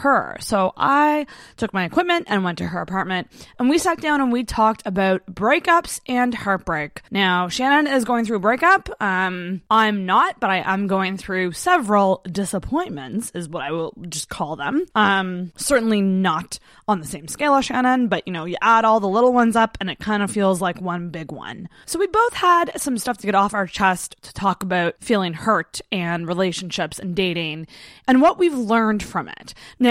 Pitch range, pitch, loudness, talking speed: 185-250 Hz, 200 Hz, -20 LUFS, 205 wpm